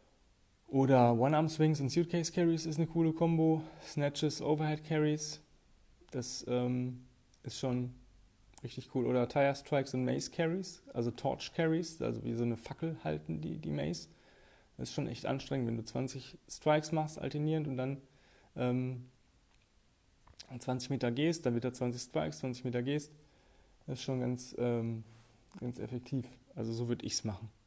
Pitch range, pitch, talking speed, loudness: 120-150 Hz, 130 Hz, 165 wpm, -35 LUFS